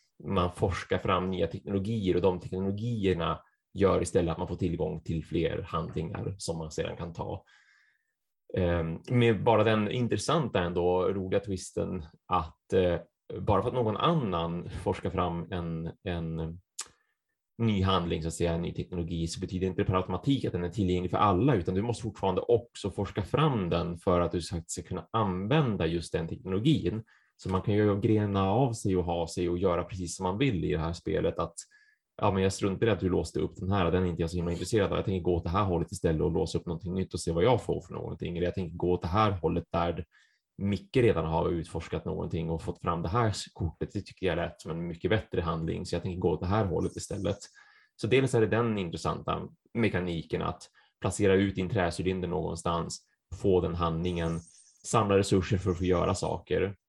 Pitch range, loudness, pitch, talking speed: 85-100 Hz, -30 LUFS, 90 Hz, 210 wpm